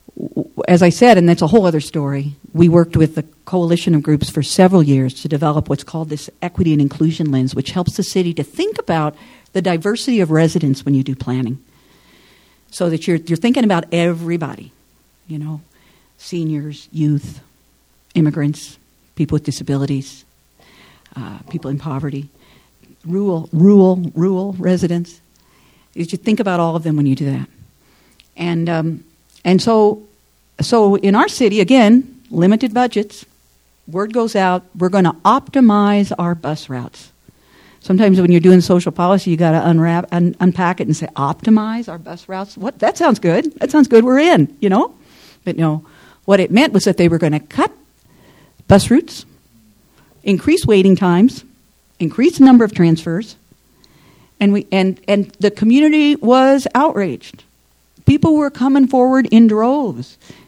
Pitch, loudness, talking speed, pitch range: 175 Hz, -14 LUFS, 160 wpm, 155-210 Hz